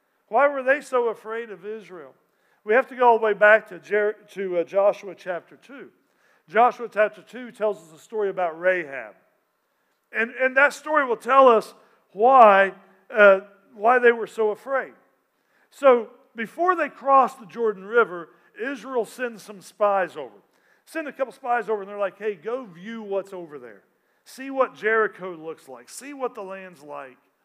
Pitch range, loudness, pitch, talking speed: 195-245 Hz, -22 LUFS, 215 Hz, 175 wpm